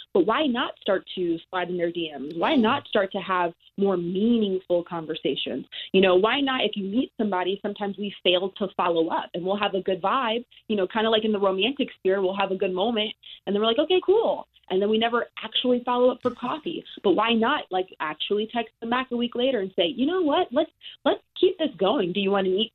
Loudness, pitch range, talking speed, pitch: -25 LUFS, 190-250 Hz, 245 wpm, 205 Hz